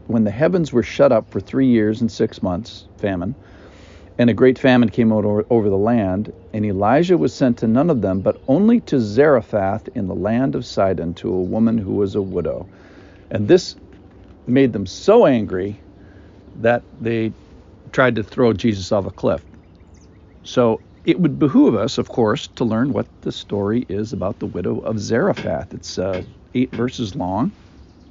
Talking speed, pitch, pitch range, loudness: 180 wpm, 105 Hz, 95-120 Hz, -19 LUFS